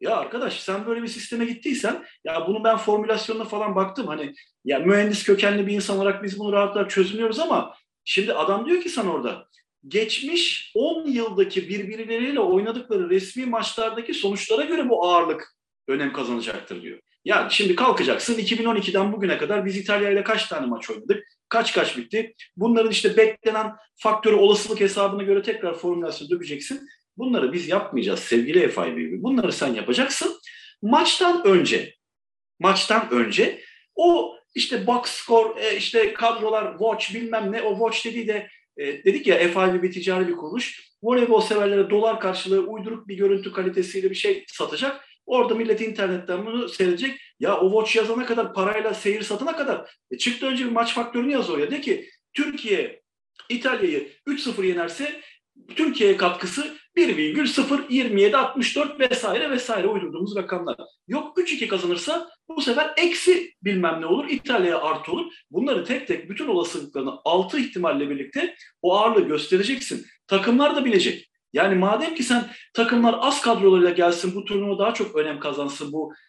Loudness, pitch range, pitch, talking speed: -22 LUFS, 200-290 Hz, 225 Hz, 150 wpm